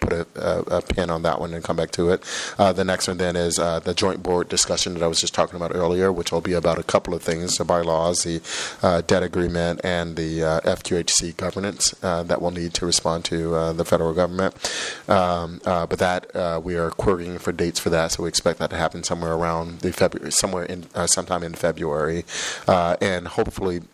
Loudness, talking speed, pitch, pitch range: -22 LUFS, 230 wpm, 85 Hz, 85-90 Hz